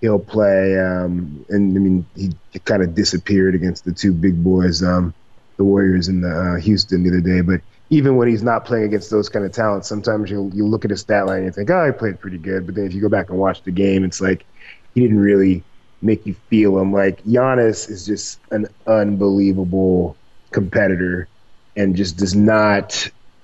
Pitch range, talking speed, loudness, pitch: 95-105 Hz, 210 wpm, -17 LUFS, 100 Hz